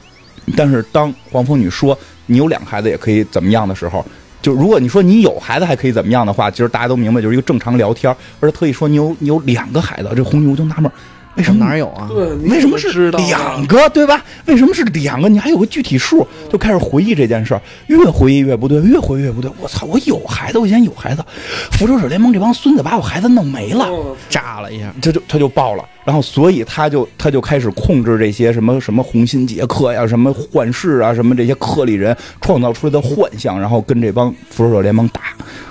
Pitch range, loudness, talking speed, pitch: 120-160 Hz, -13 LUFS, 355 characters per minute, 135 Hz